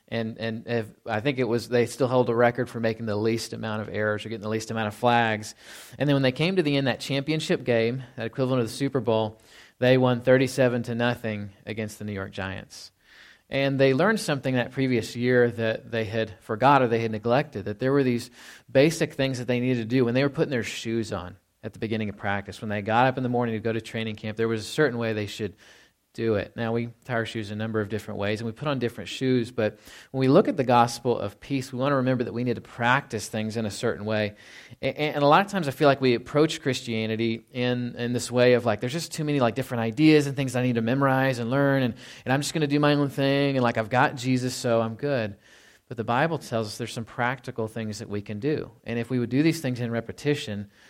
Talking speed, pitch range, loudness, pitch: 260 wpm, 110-135 Hz, -25 LUFS, 120 Hz